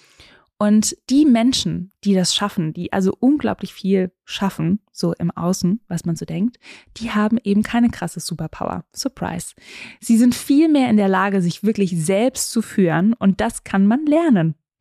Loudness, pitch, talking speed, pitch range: -19 LUFS, 200 Hz, 165 wpm, 180-230 Hz